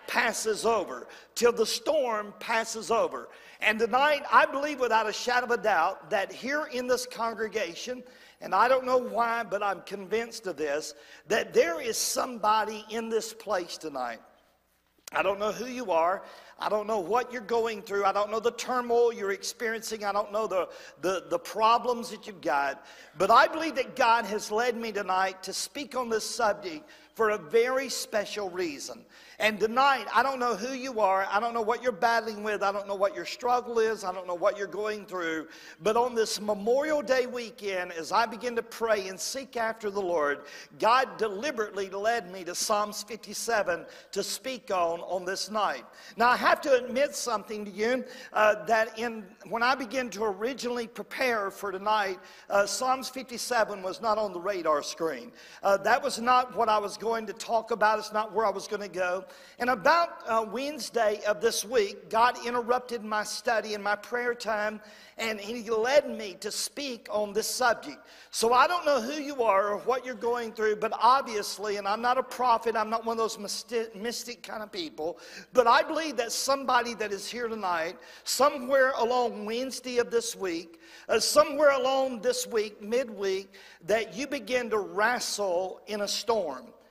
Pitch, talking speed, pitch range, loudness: 225 Hz, 190 wpm, 205-250 Hz, -28 LUFS